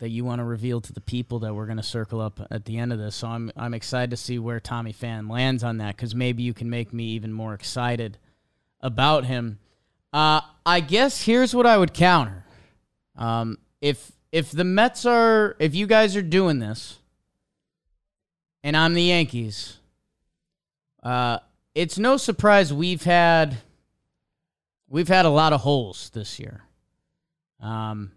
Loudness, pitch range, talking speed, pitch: -22 LUFS, 115-165 Hz, 175 wpm, 125 Hz